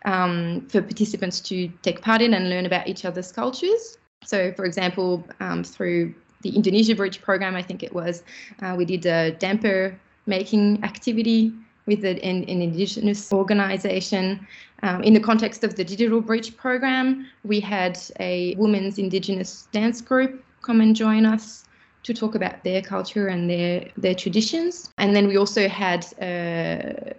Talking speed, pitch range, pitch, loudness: 160 wpm, 185-220 Hz, 195 Hz, -23 LUFS